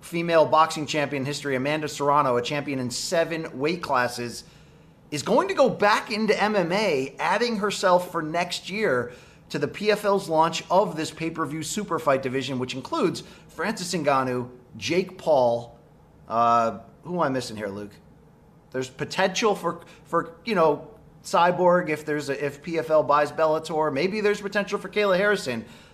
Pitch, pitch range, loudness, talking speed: 160 Hz, 140-180 Hz, -24 LUFS, 155 wpm